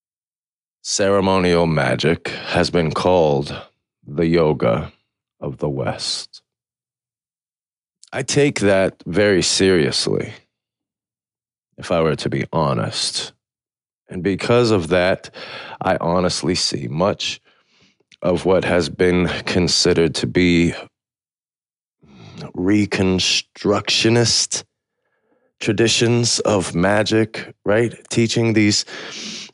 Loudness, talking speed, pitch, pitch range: -18 LUFS, 85 wpm, 100 Hz, 90-115 Hz